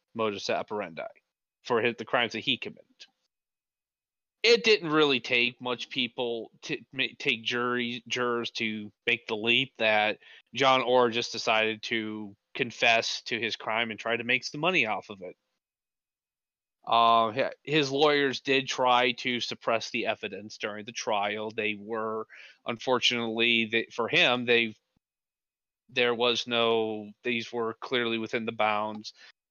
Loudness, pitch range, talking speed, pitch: -27 LUFS, 110-125 Hz, 145 wpm, 115 Hz